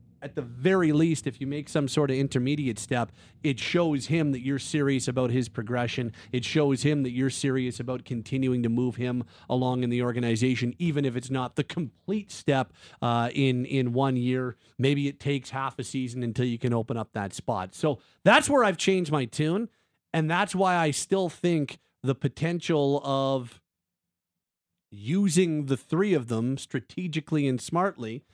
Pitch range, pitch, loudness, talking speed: 125-150 Hz, 135 Hz, -27 LUFS, 180 wpm